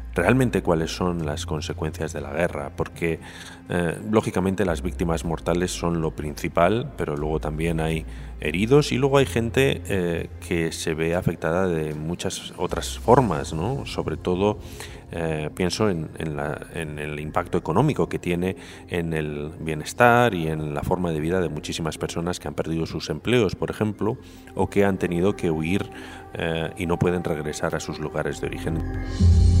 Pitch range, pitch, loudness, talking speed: 80-95 Hz, 85 Hz, -24 LUFS, 170 wpm